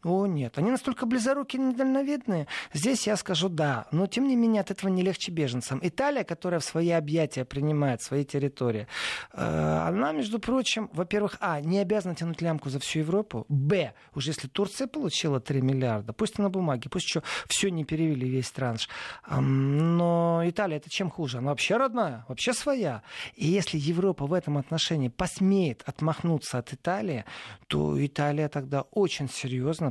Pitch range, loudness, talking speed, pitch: 140-195 Hz, -28 LUFS, 165 wpm, 165 Hz